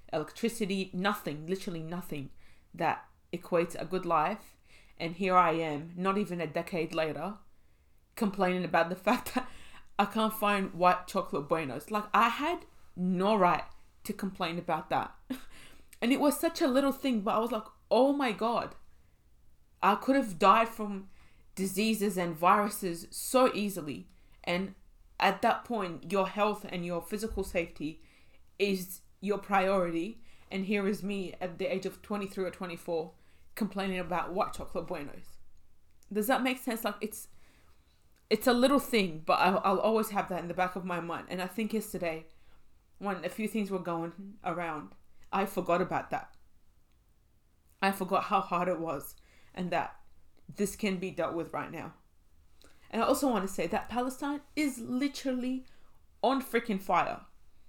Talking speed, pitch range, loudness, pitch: 165 wpm, 170-215 Hz, -31 LUFS, 190 Hz